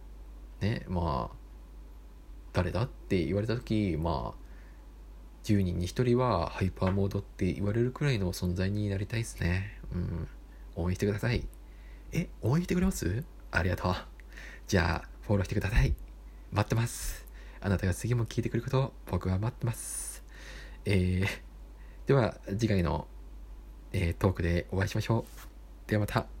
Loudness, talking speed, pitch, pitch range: -32 LUFS, 295 characters per minute, 95 Hz, 80-110 Hz